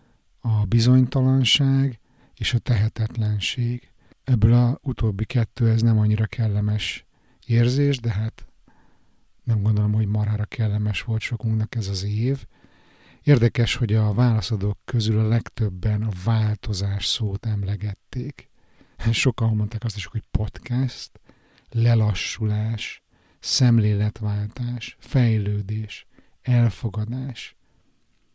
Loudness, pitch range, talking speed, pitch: -23 LUFS, 105-120 Hz, 100 wpm, 110 Hz